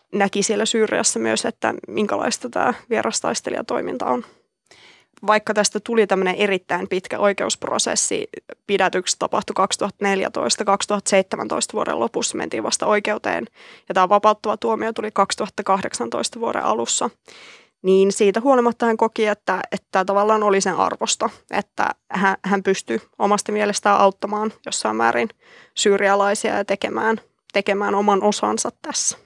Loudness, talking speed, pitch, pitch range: -20 LUFS, 120 wpm, 205 Hz, 195-215 Hz